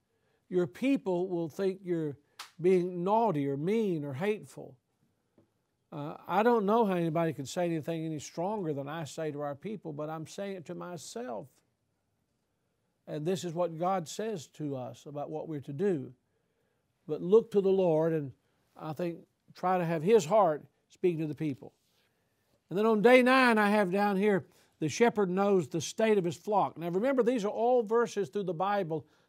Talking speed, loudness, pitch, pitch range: 185 wpm, -30 LUFS, 175 Hz, 155-205 Hz